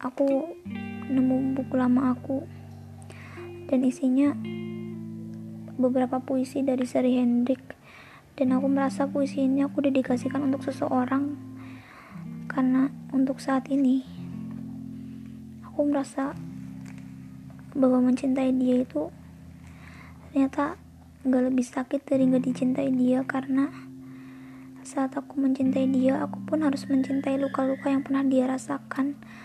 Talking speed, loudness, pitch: 105 wpm, -26 LUFS, 260 Hz